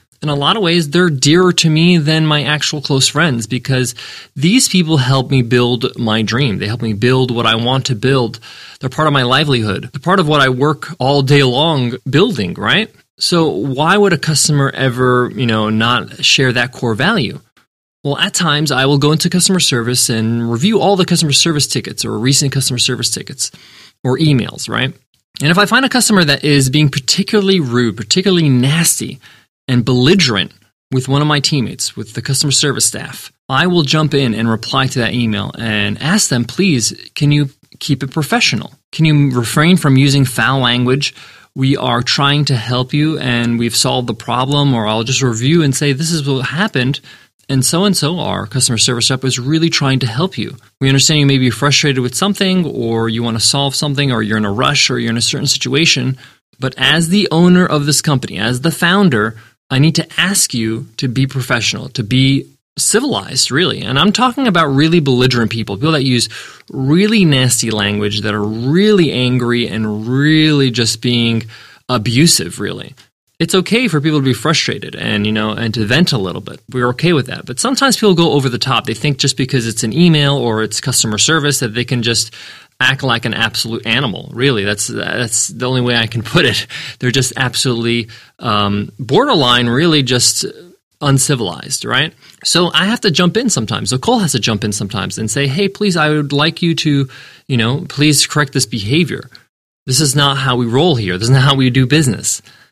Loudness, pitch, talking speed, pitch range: -13 LUFS, 135 Hz, 205 wpm, 120-155 Hz